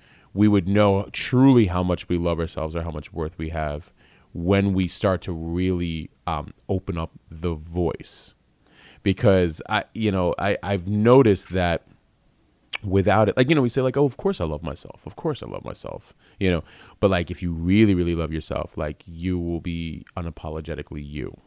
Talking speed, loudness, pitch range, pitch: 190 wpm, -23 LUFS, 80-100 Hz, 90 Hz